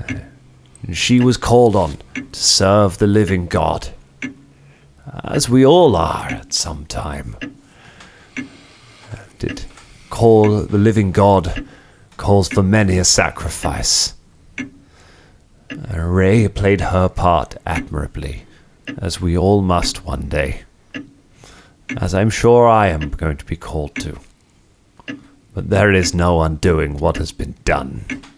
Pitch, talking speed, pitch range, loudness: 95 Hz, 125 wpm, 85-105 Hz, -16 LUFS